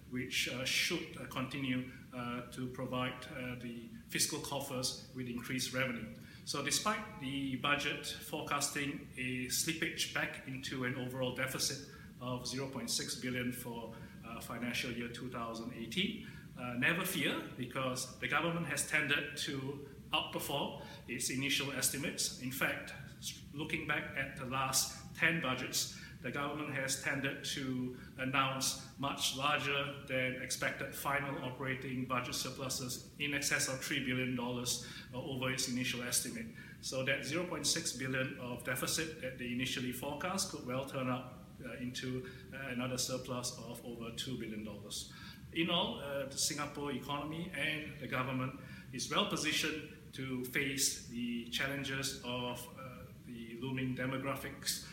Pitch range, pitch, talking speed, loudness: 125-145 Hz, 130 Hz, 135 wpm, -37 LUFS